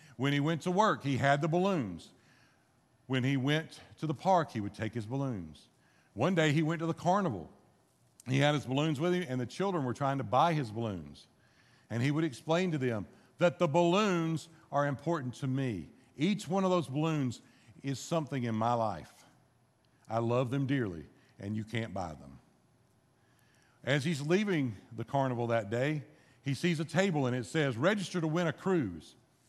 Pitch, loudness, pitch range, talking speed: 135 Hz, -32 LUFS, 120-165 Hz, 190 wpm